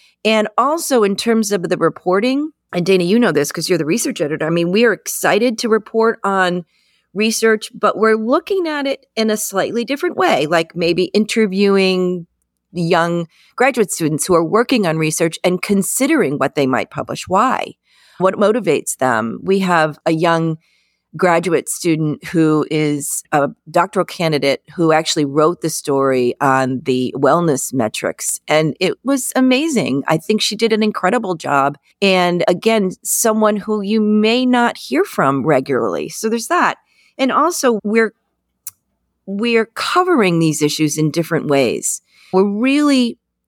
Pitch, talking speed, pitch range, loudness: 190 Hz, 155 wpm, 160-225 Hz, -16 LUFS